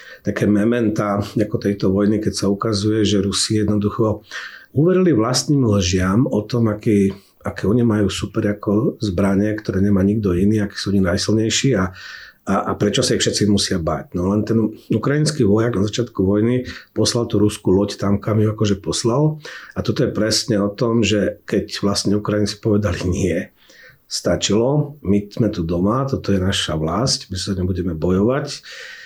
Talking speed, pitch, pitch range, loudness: 170 wpm, 105 Hz, 100-115 Hz, -19 LUFS